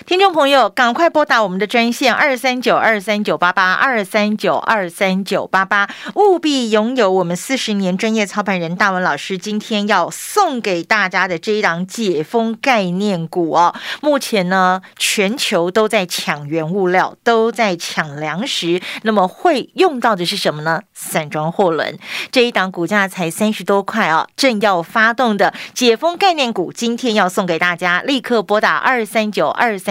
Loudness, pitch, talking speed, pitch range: -15 LUFS, 210 Hz, 265 characters per minute, 185-235 Hz